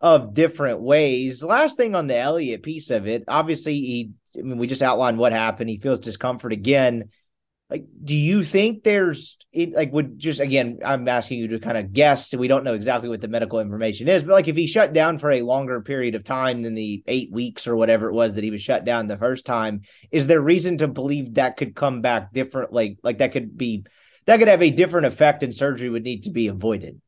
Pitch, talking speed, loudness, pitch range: 130 Hz, 235 wpm, -21 LUFS, 115-155 Hz